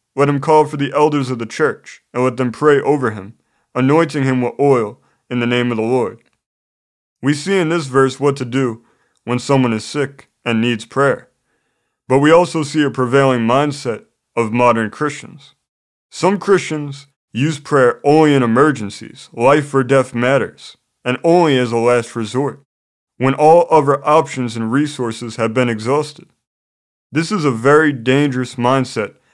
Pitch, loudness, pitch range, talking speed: 135 Hz, -15 LUFS, 120-150 Hz, 170 wpm